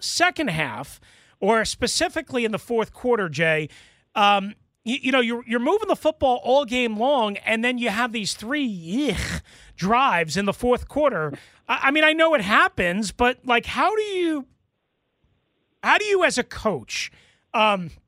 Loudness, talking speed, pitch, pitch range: -22 LUFS, 175 wpm, 245 Hz, 205-285 Hz